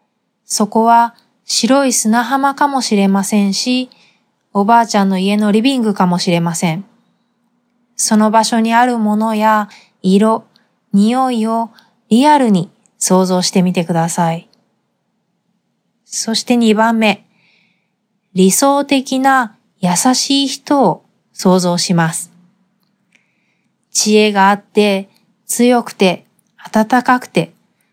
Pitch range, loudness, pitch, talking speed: 195-235 Hz, -13 LUFS, 215 Hz, 205 characters per minute